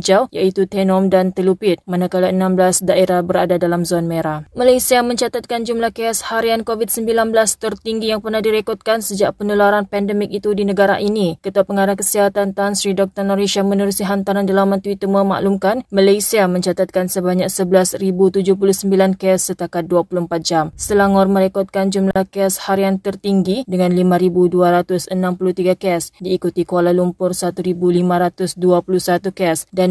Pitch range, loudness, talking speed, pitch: 180-200 Hz, -16 LUFS, 130 wpm, 195 Hz